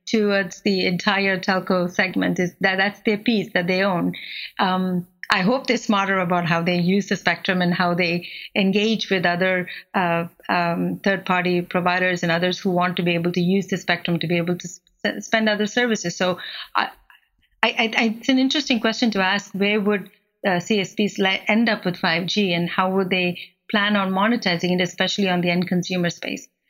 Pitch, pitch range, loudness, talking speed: 190 Hz, 180-205 Hz, -21 LUFS, 195 wpm